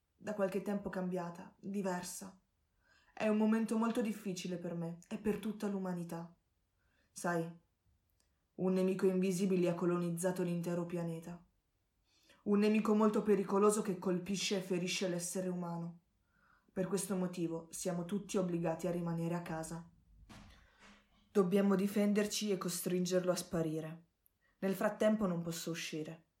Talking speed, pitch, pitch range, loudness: 125 wpm, 185 Hz, 170-200 Hz, -36 LUFS